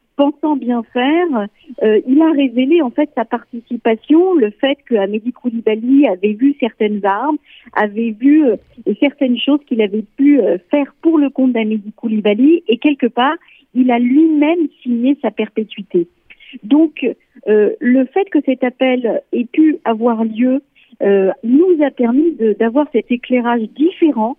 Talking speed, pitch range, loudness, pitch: 150 wpm, 225-290 Hz, -15 LUFS, 255 Hz